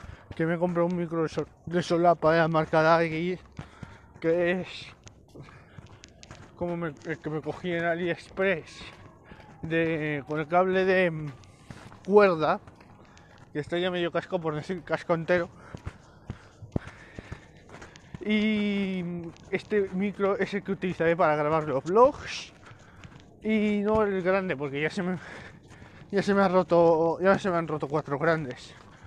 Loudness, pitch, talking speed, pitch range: -27 LUFS, 170 Hz, 140 wpm, 155-185 Hz